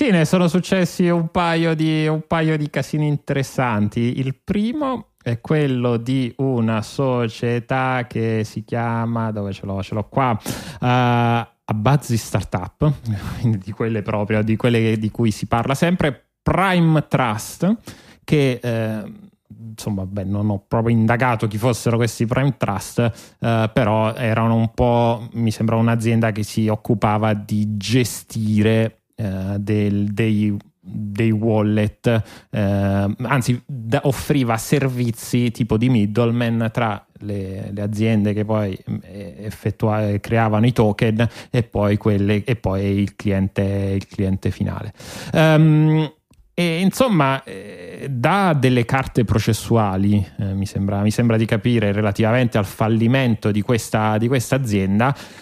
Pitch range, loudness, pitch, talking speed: 105-130 Hz, -20 LUFS, 115 Hz, 130 wpm